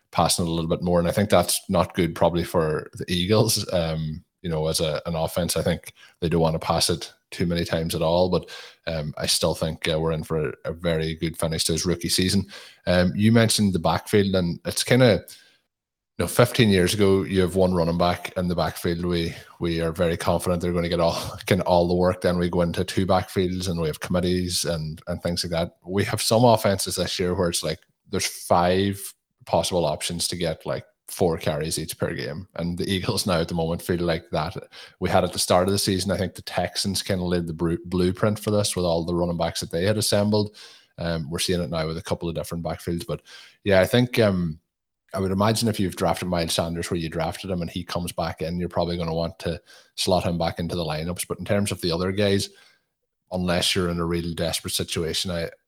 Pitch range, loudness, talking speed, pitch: 85-95 Hz, -24 LUFS, 240 wpm, 90 Hz